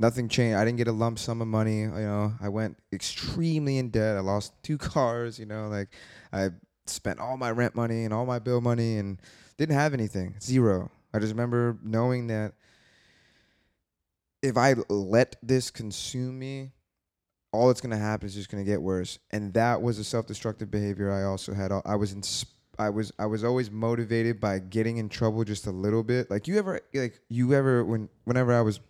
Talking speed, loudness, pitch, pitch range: 205 wpm, -28 LUFS, 115 Hz, 105-120 Hz